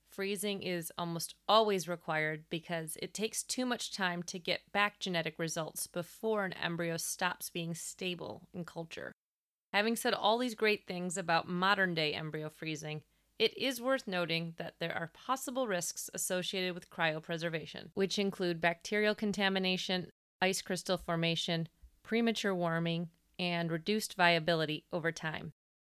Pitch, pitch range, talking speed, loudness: 180 Hz, 165-200 Hz, 140 wpm, -34 LUFS